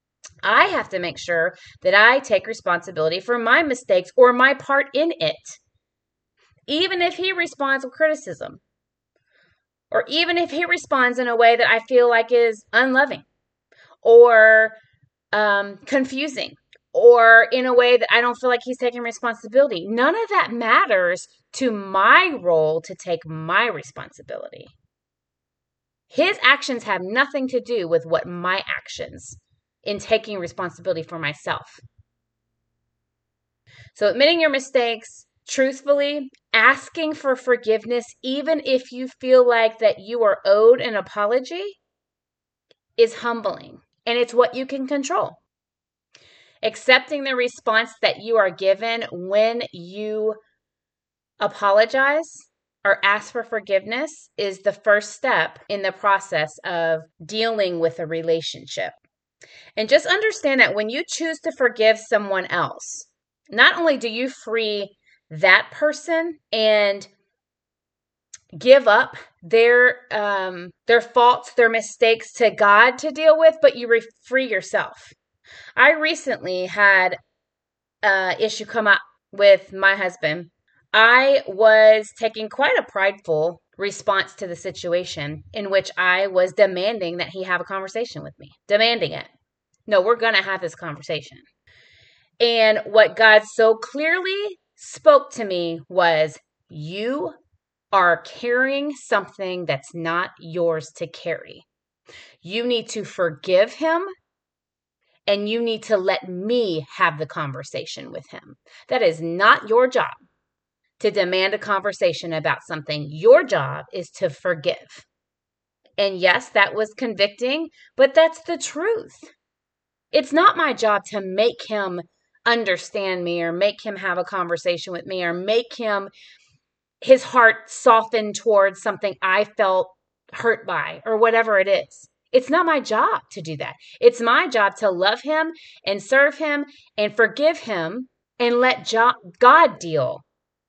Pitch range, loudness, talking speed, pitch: 190-260 Hz, -19 LUFS, 140 wpm, 220 Hz